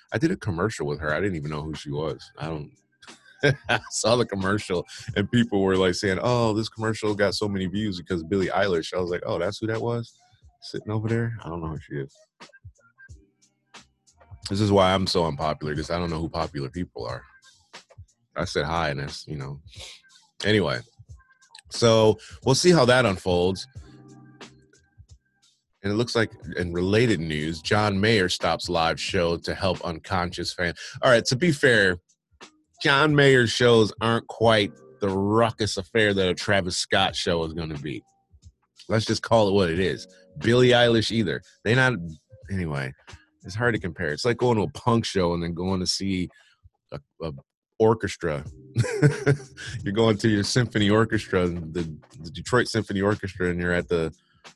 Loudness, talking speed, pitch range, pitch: -24 LUFS, 180 wpm, 85-115 Hz, 100 Hz